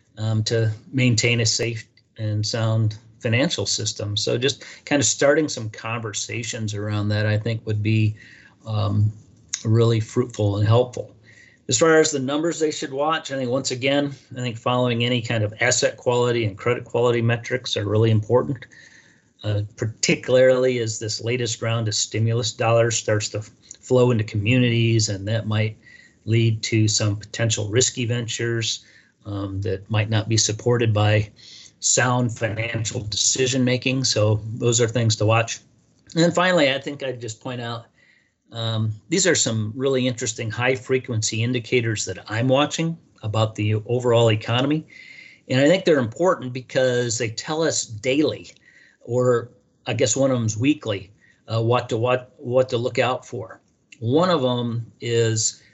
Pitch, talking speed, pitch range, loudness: 115 Hz, 160 wpm, 110-125 Hz, -21 LUFS